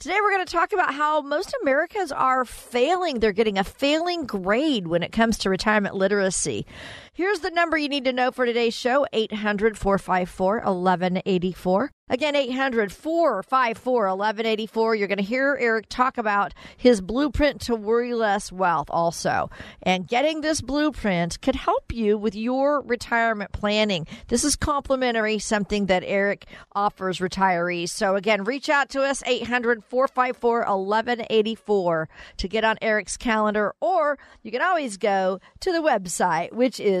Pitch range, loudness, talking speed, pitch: 200-270 Hz, -23 LUFS, 145 wpm, 225 Hz